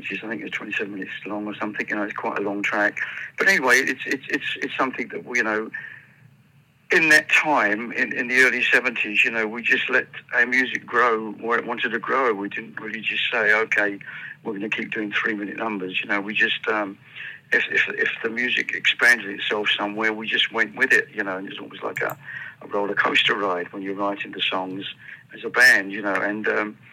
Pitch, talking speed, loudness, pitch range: 105 Hz, 225 wpm, -21 LUFS, 100-110 Hz